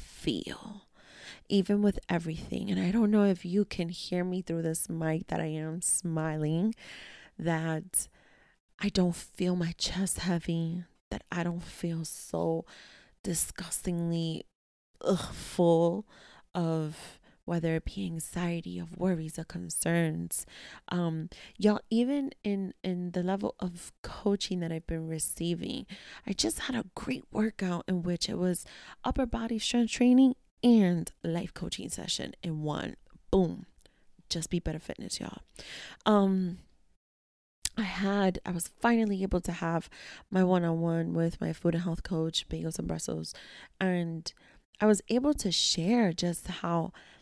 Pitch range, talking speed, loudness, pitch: 165-200 Hz, 145 wpm, -31 LUFS, 175 Hz